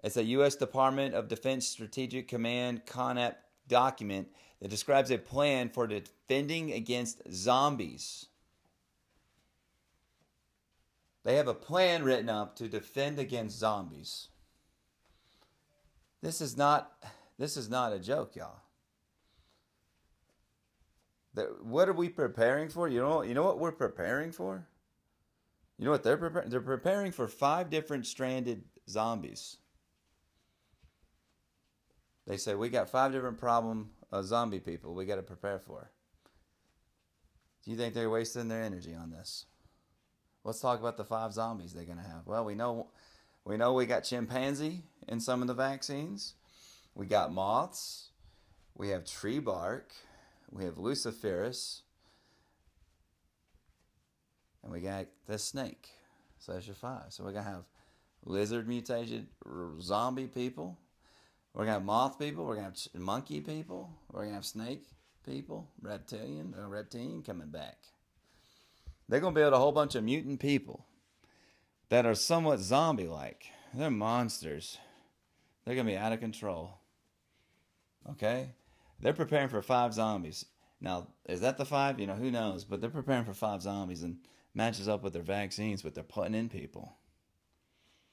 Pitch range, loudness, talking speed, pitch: 95-130 Hz, -34 LUFS, 150 wpm, 115 Hz